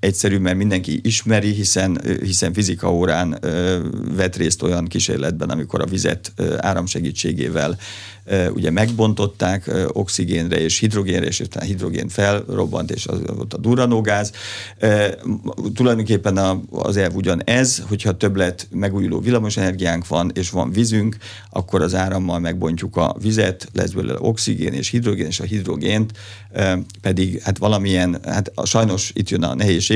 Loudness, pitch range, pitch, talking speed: -19 LUFS, 90-105 Hz, 95 Hz, 140 wpm